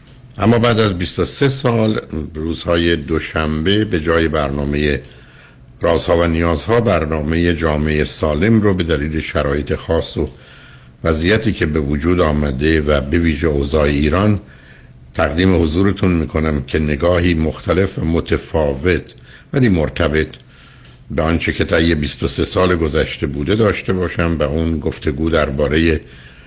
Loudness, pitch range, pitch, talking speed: -16 LUFS, 75-90 Hz, 80 Hz, 125 wpm